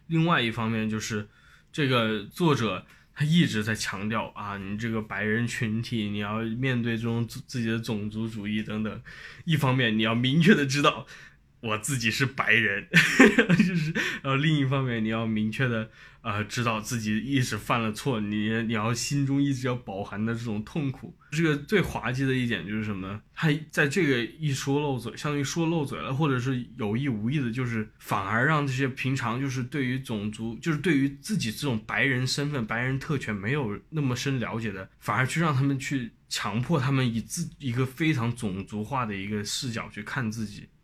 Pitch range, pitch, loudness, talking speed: 110-140 Hz, 120 Hz, -27 LUFS, 290 characters per minute